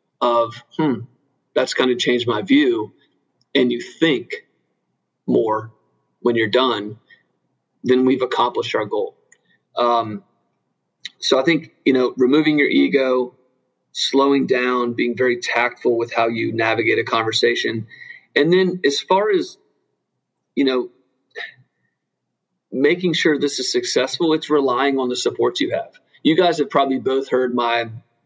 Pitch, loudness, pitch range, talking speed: 130 Hz, -19 LUFS, 120-170 Hz, 145 wpm